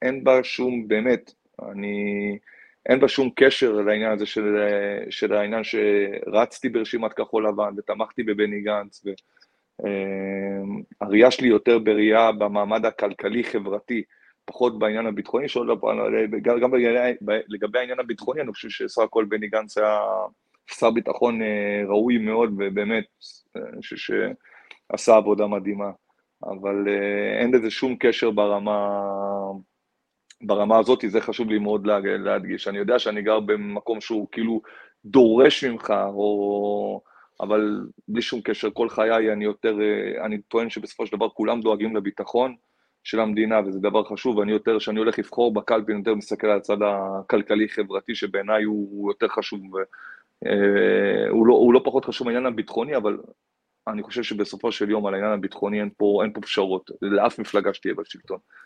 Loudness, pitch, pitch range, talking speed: -23 LUFS, 105 Hz, 100-115 Hz, 140 wpm